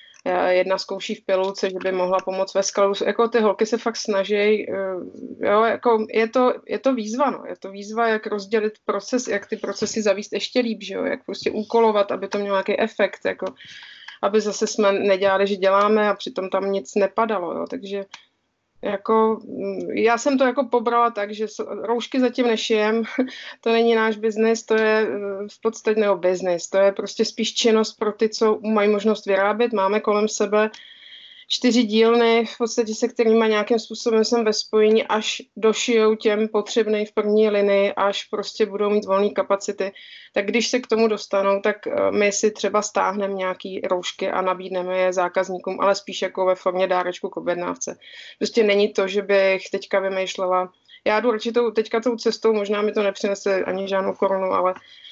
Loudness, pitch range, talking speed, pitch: -21 LUFS, 195-225 Hz, 180 wpm, 210 Hz